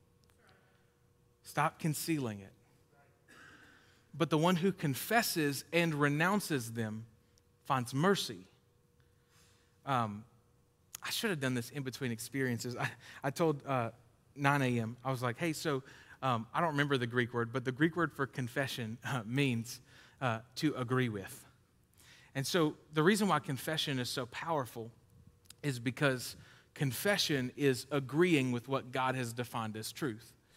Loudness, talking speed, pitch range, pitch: -34 LUFS, 145 wpm, 120-145 Hz, 130 Hz